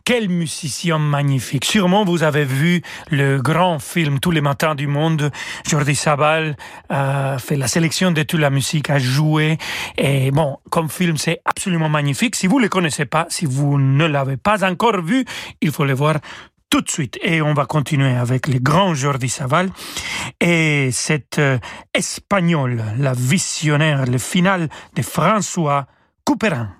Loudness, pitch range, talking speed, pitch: -18 LUFS, 140-175 Hz, 170 wpm, 155 Hz